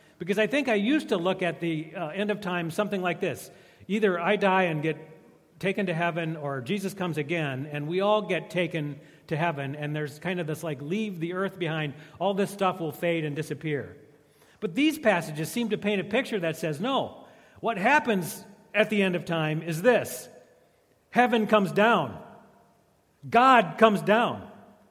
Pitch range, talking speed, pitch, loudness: 160-210 Hz, 190 wpm, 180 Hz, -27 LUFS